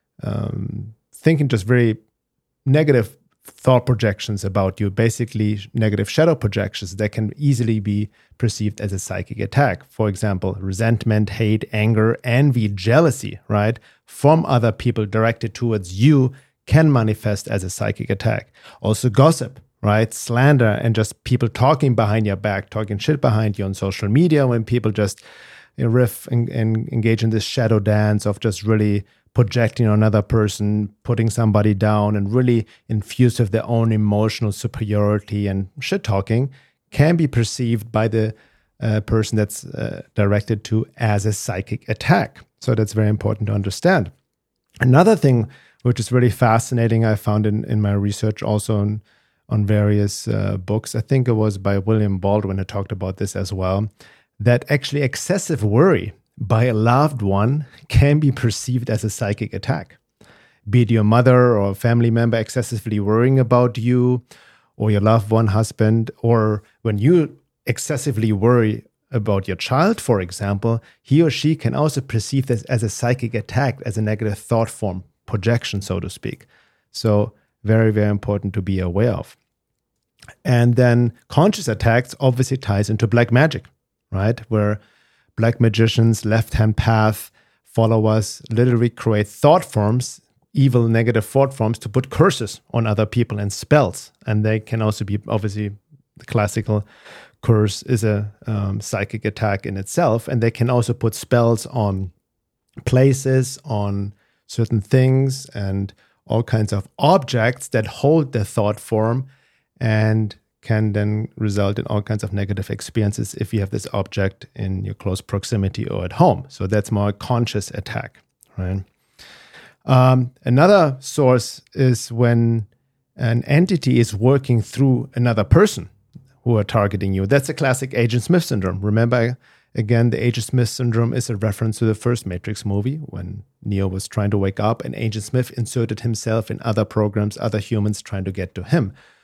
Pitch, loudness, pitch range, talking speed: 110 Hz, -19 LUFS, 105-125 Hz, 160 wpm